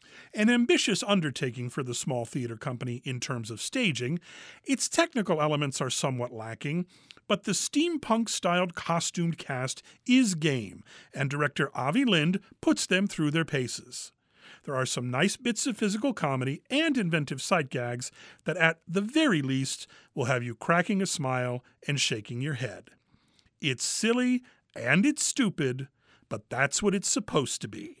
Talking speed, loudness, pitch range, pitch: 160 wpm, -28 LUFS, 130-210 Hz, 160 Hz